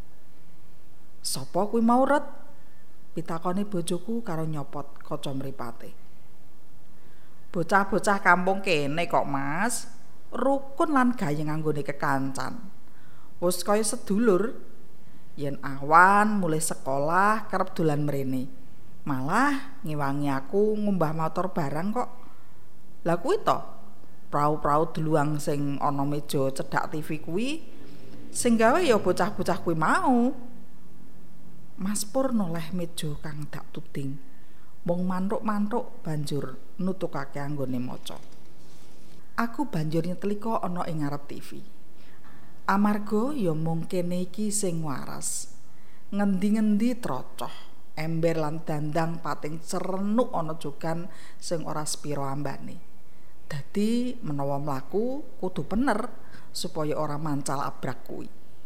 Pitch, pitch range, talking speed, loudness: 170 Hz, 145-210 Hz, 100 wpm, -27 LUFS